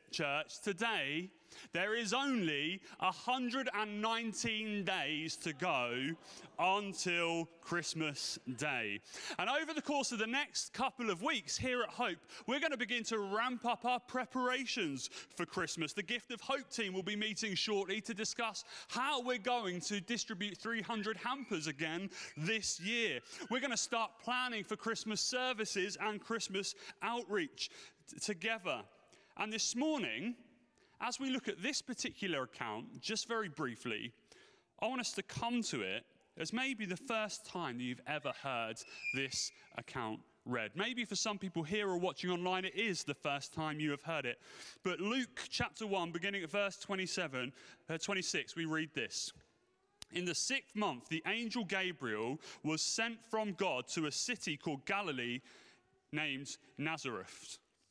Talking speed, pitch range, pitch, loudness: 155 wpm, 165-235 Hz, 205 Hz, -38 LUFS